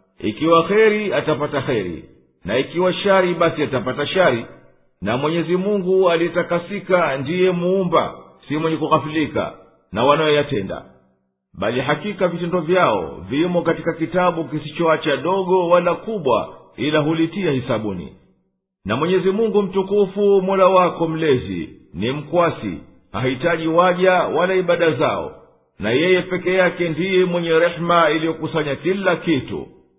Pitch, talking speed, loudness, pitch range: 165 Hz, 120 wpm, -19 LUFS, 140-180 Hz